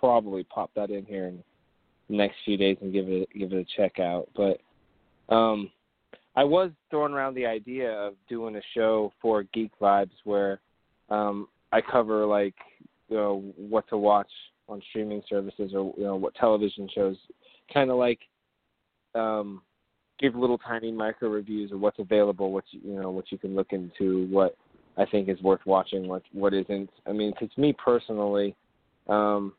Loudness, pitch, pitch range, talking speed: -27 LUFS, 105 Hz, 95-110 Hz, 180 wpm